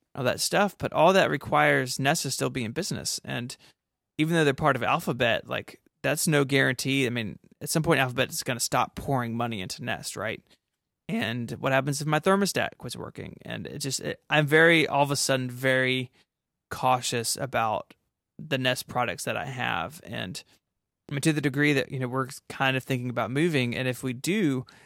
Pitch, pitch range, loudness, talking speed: 135 Hz, 125-145 Hz, -26 LUFS, 205 wpm